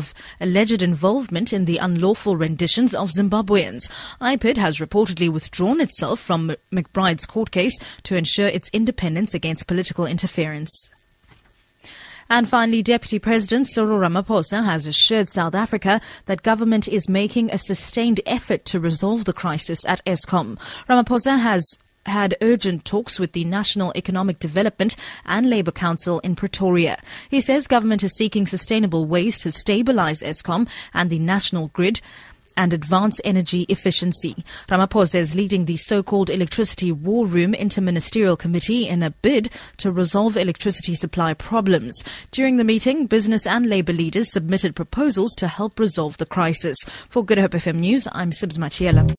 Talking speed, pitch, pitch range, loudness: 150 wpm, 195 Hz, 175-220 Hz, -20 LUFS